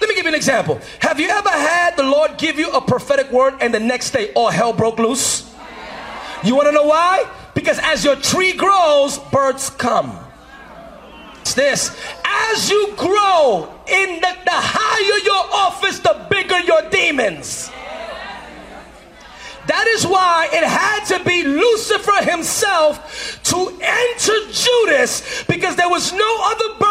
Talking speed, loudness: 155 wpm, -15 LUFS